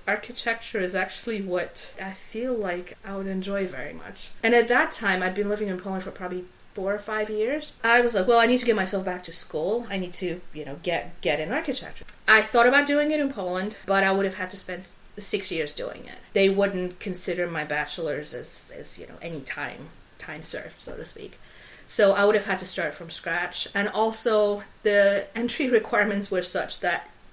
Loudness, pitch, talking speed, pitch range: -25 LUFS, 200 Hz, 215 wpm, 185-225 Hz